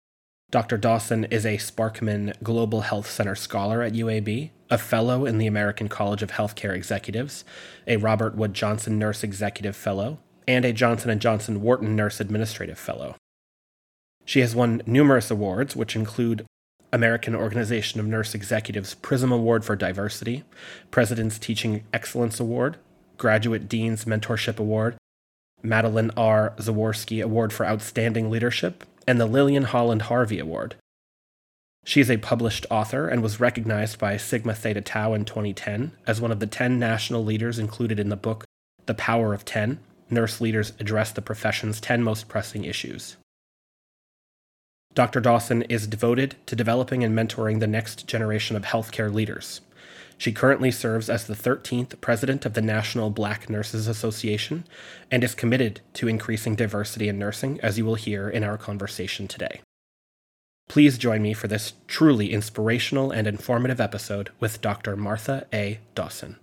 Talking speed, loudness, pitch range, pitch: 155 wpm, -25 LUFS, 105-120 Hz, 110 Hz